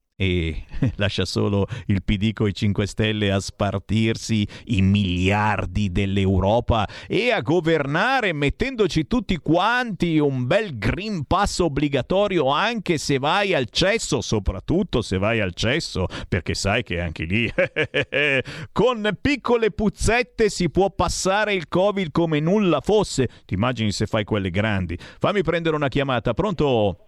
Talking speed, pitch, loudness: 135 wpm, 130 Hz, -22 LUFS